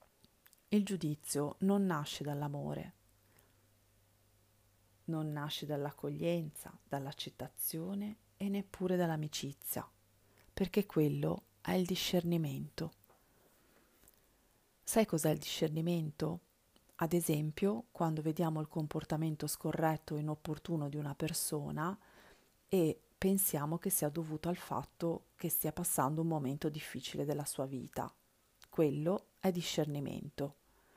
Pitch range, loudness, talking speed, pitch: 145-170 Hz, -37 LUFS, 100 wpm, 155 Hz